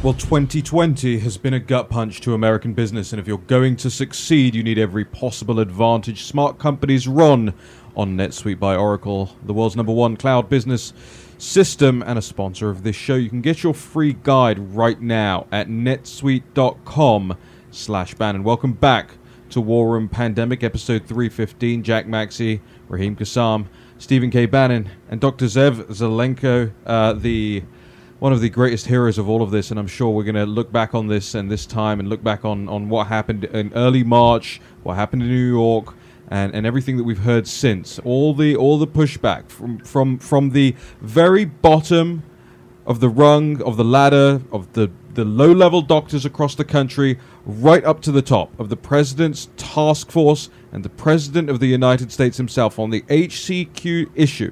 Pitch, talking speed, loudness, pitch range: 120 Hz, 185 wpm, -18 LUFS, 110-135 Hz